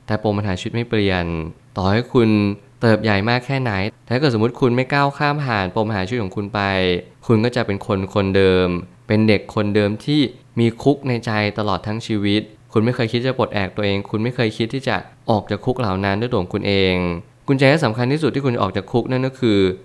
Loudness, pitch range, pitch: -19 LUFS, 100-125 Hz, 110 Hz